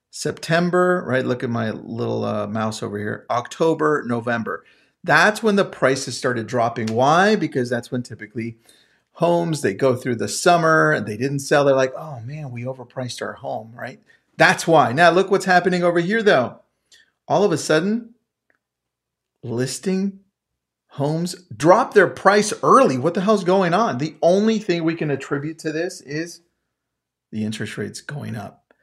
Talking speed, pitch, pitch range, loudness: 165 wpm, 150 Hz, 120-180 Hz, -19 LUFS